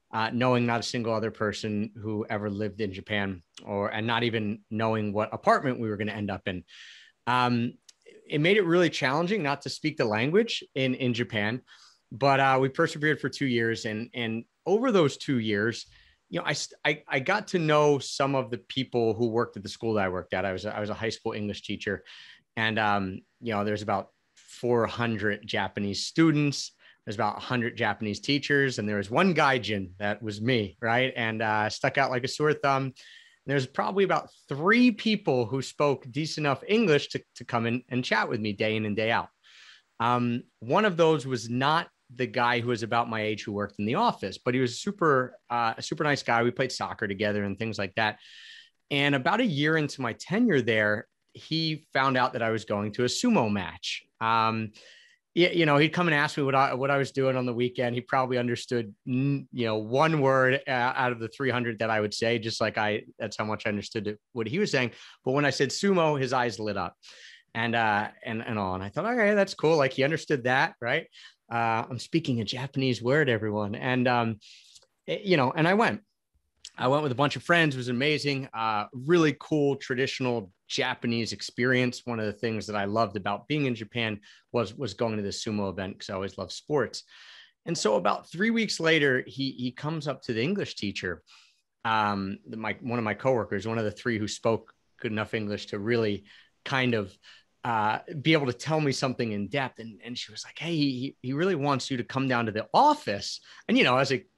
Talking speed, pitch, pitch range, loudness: 220 wpm, 120 Hz, 110-140 Hz, -27 LUFS